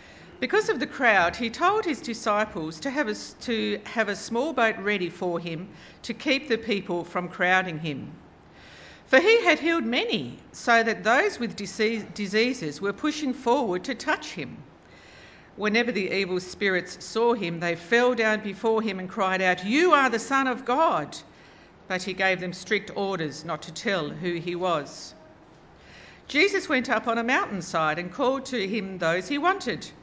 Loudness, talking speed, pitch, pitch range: -25 LUFS, 175 wpm, 215 Hz, 180-250 Hz